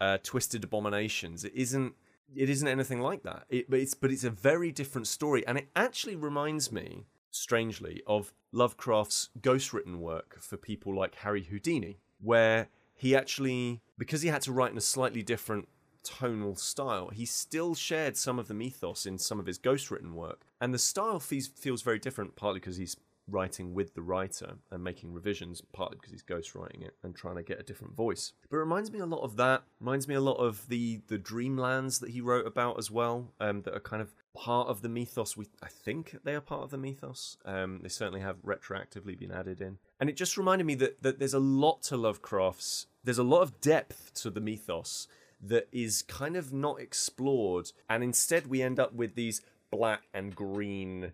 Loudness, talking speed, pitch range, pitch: -33 LUFS, 205 wpm, 100-135 Hz, 120 Hz